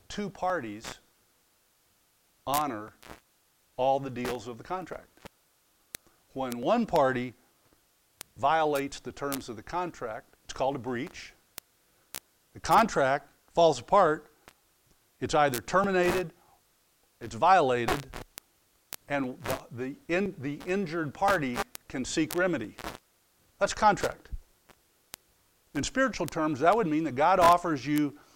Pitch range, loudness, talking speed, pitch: 130-180 Hz, -28 LUFS, 115 wpm, 155 Hz